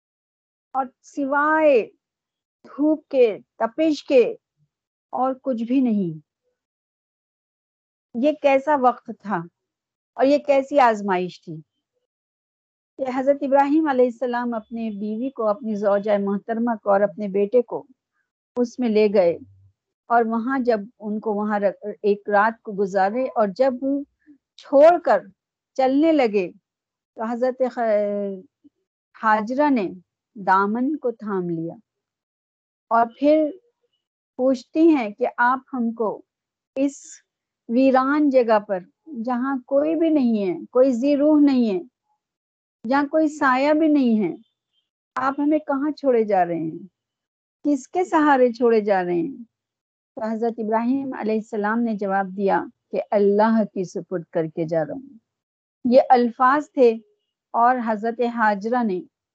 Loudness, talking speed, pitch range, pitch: -21 LUFS, 130 wpm, 205-280 Hz, 240 Hz